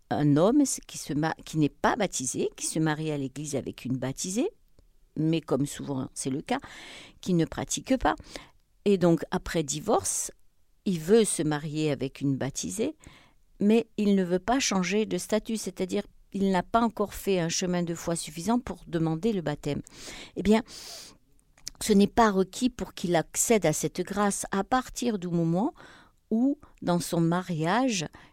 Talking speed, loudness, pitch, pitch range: 170 wpm, -28 LUFS, 180 Hz, 155-215 Hz